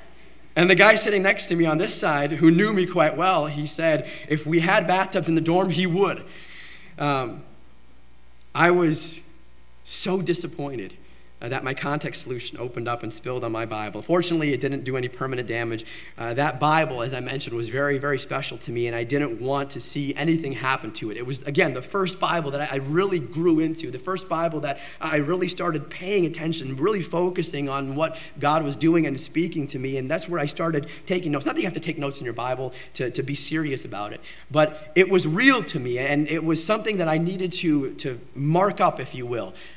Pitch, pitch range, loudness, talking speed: 150 Hz, 130-170 Hz, -23 LUFS, 220 wpm